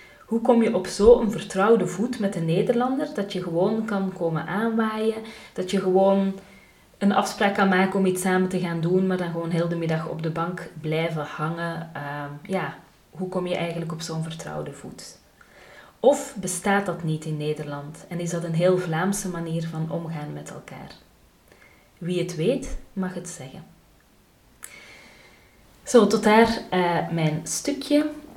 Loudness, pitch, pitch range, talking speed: -24 LUFS, 185 Hz, 165-200 Hz, 165 wpm